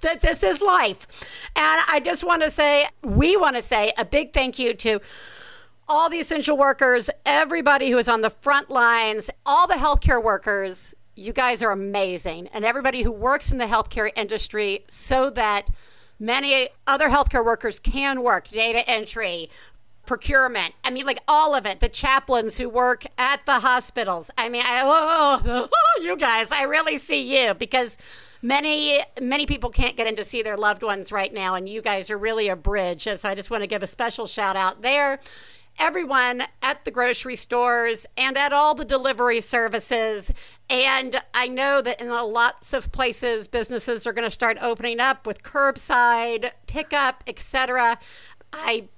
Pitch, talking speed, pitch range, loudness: 245 Hz, 175 wpm, 225-275 Hz, -21 LUFS